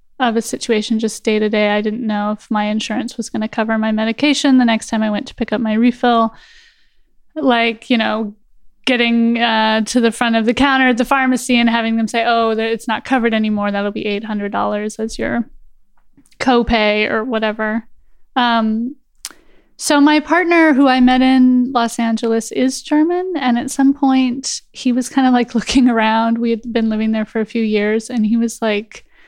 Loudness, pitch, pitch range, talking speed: -16 LUFS, 230 Hz, 220-255 Hz, 195 wpm